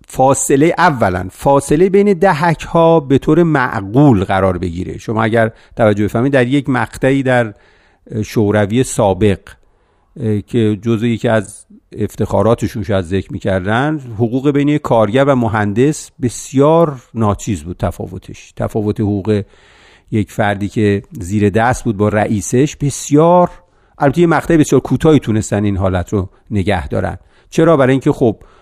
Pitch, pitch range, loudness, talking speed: 115 Hz, 105-140 Hz, -14 LUFS, 135 wpm